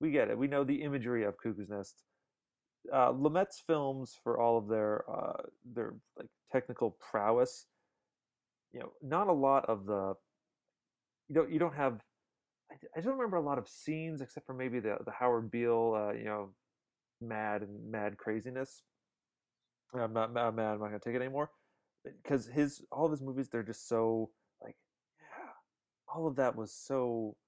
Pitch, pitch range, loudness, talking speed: 120 Hz, 110-140 Hz, -35 LUFS, 175 wpm